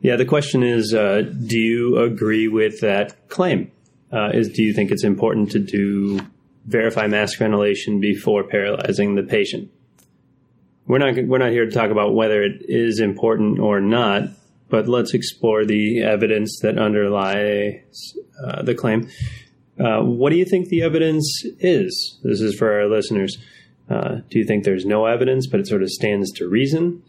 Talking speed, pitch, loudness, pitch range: 175 wpm, 110 Hz, -19 LUFS, 105-120 Hz